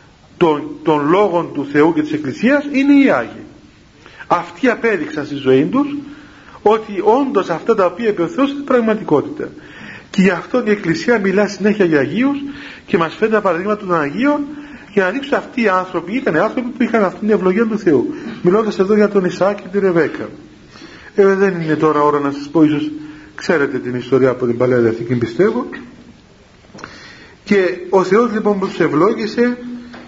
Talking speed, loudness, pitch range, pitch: 175 wpm, -15 LUFS, 160-245 Hz, 200 Hz